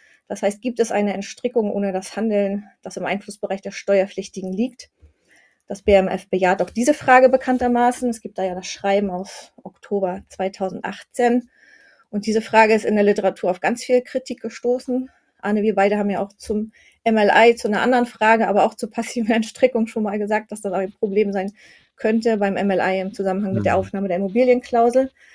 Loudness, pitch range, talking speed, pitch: -20 LUFS, 195-235 Hz, 185 wpm, 210 Hz